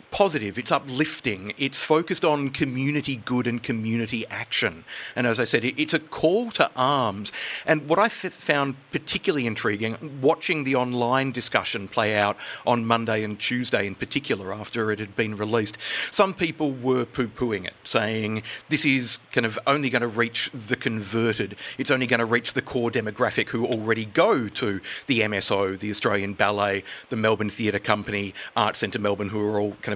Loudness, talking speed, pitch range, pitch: -24 LUFS, 180 wpm, 105-140 Hz, 120 Hz